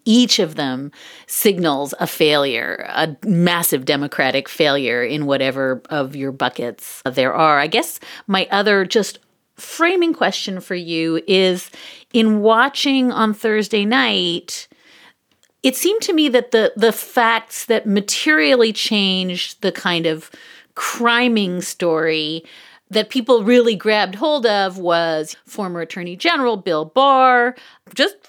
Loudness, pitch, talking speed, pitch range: -17 LUFS, 205 Hz, 130 wpm, 165-240 Hz